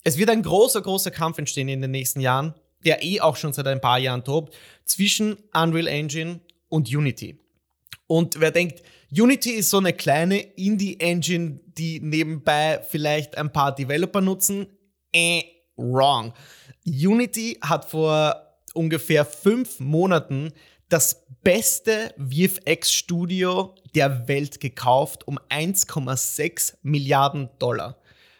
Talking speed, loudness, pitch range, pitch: 125 wpm, -22 LUFS, 140-180 Hz, 160 Hz